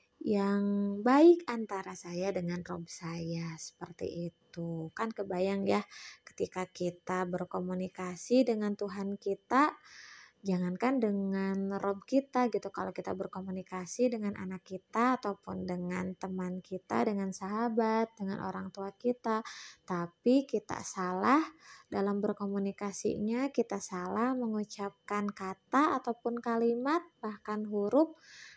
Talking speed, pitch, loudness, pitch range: 110 wpm, 200 Hz, -33 LUFS, 185-230 Hz